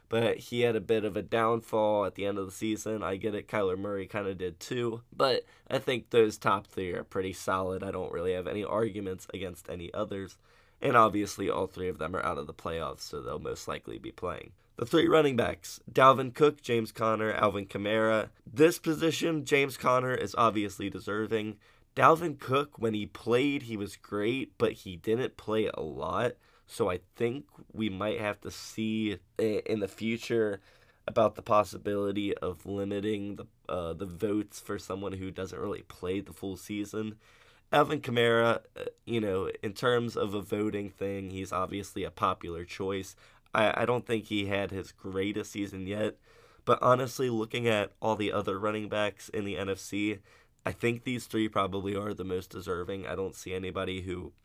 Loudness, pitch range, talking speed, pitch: -31 LUFS, 100-115 Hz, 185 wpm, 105 Hz